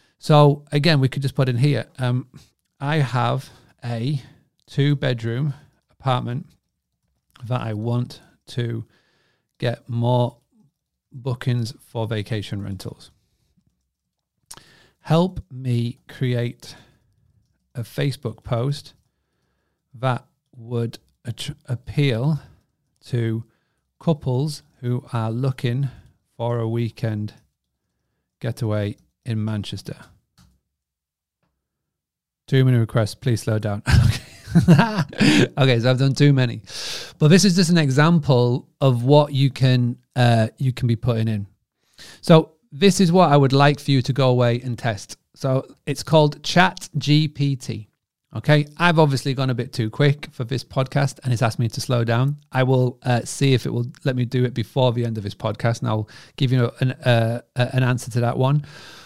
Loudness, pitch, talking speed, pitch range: -21 LUFS, 125 Hz, 140 wpm, 115-140 Hz